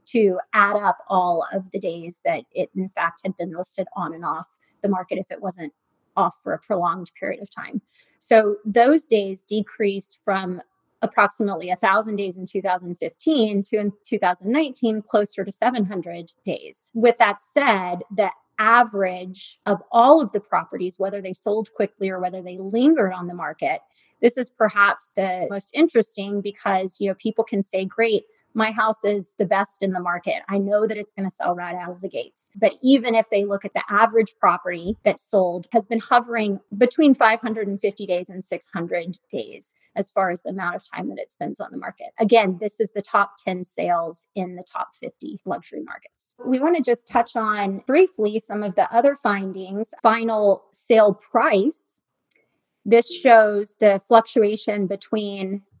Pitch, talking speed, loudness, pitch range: 205 Hz, 180 wpm, -21 LUFS, 190-225 Hz